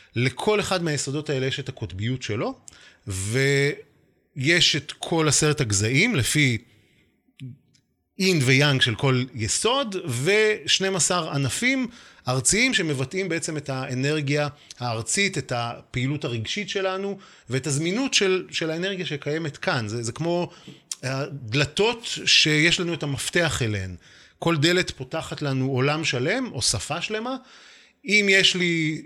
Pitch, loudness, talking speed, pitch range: 150 Hz, -23 LUFS, 120 wpm, 130-185 Hz